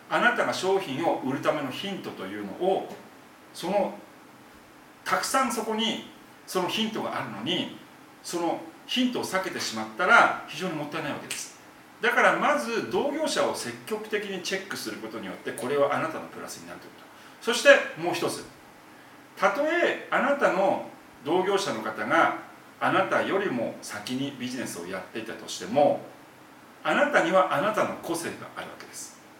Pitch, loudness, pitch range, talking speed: 195 Hz, -26 LUFS, 160-270 Hz, 345 characters per minute